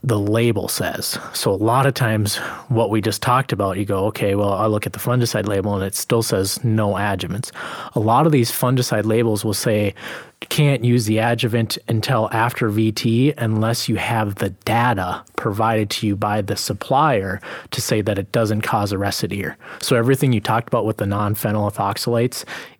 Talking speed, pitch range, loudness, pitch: 190 wpm, 105-120 Hz, -19 LUFS, 110 Hz